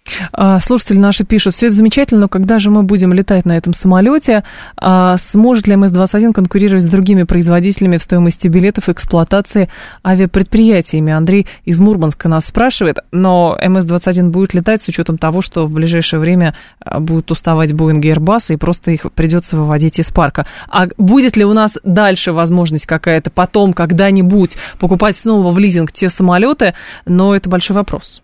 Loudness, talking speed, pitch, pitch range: -11 LUFS, 165 wpm, 185 Hz, 170-200 Hz